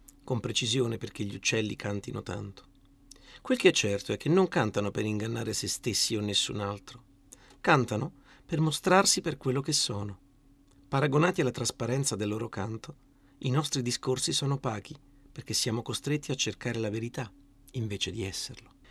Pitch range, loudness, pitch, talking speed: 105-140 Hz, -29 LUFS, 125 Hz, 160 wpm